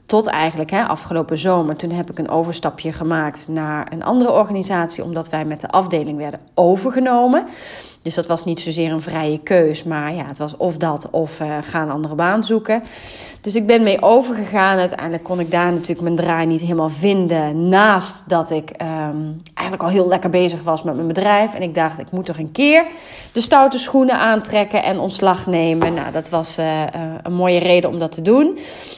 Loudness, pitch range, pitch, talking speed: -17 LUFS, 160-195 Hz, 170 Hz, 200 wpm